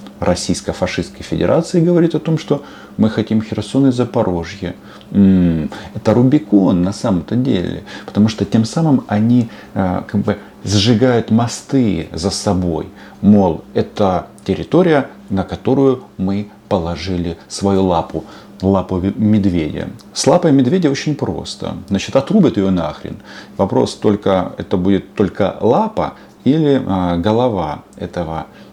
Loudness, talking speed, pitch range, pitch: -16 LUFS, 120 wpm, 95-120 Hz, 100 Hz